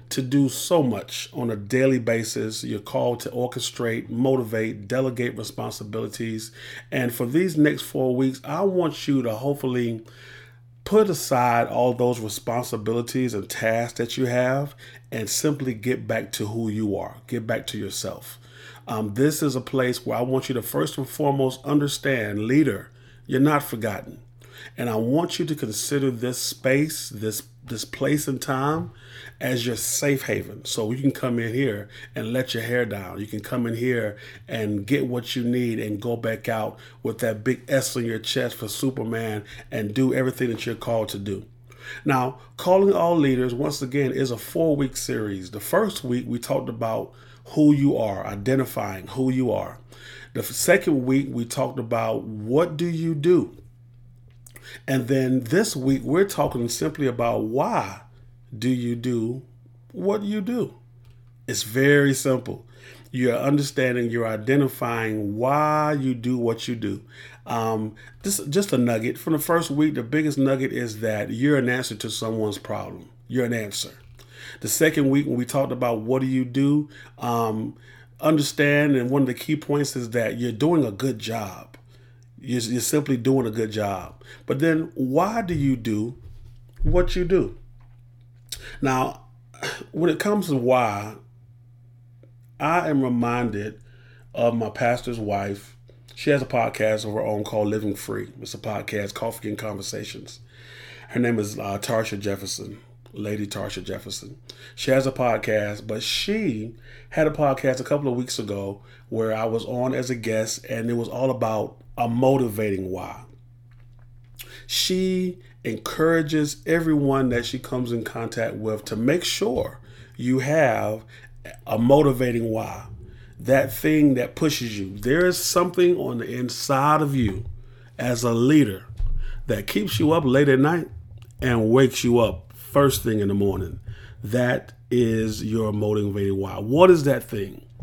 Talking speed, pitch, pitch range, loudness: 165 wpm, 120 Hz, 115-135 Hz, -24 LUFS